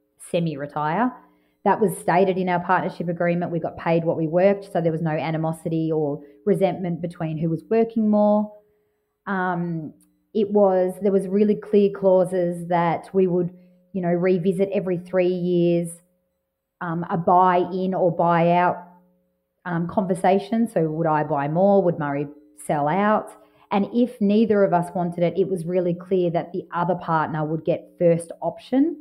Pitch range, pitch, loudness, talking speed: 165-190 Hz, 180 Hz, -22 LUFS, 160 wpm